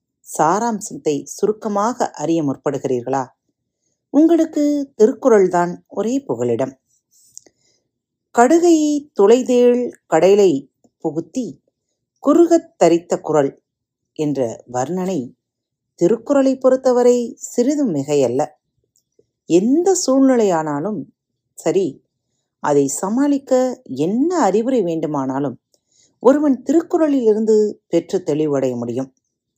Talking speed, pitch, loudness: 70 wpm, 210 Hz, -17 LUFS